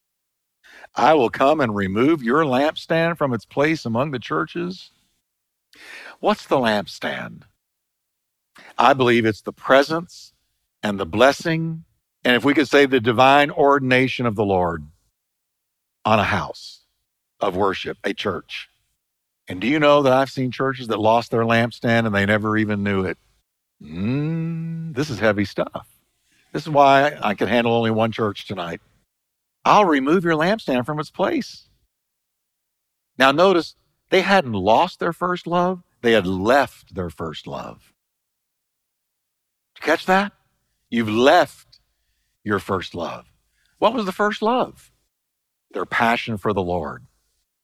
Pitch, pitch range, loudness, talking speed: 130 Hz, 110-160 Hz, -20 LUFS, 145 wpm